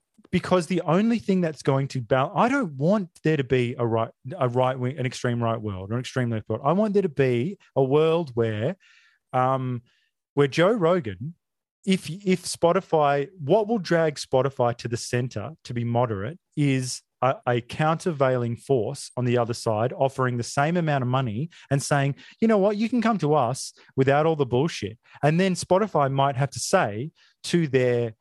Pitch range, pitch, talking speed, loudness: 125-170 Hz, 140 Hz, 195 wpm, -24 LUFS